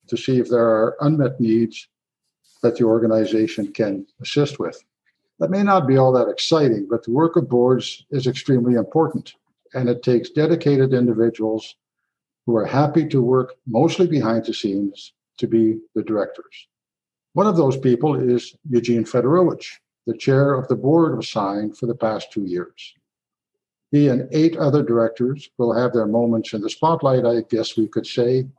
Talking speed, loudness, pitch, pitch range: 170 wpm, -19 LUFS, 125 Hz, 115-145 Hz